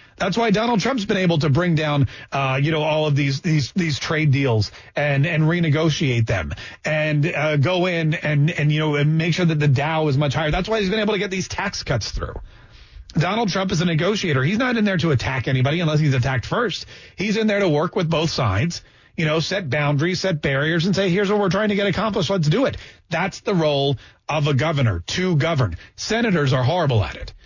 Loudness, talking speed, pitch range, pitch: -20 LUFS, 230 wpm, 140-185 Hz, 155 Hz